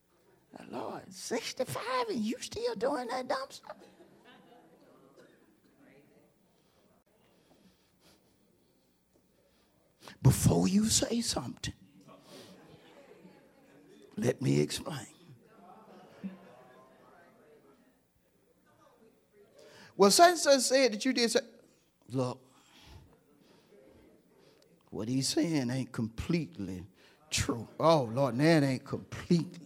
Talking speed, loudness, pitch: 75 wpm, -30 LUFS, 170 Hz